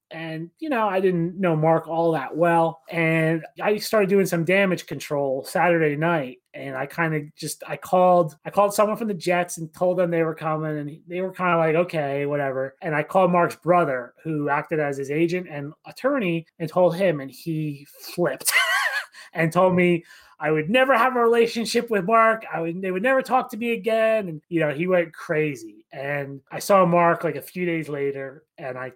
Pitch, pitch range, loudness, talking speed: 165 Hz, 155-185 Hz, -22 LUFS, 210 wpm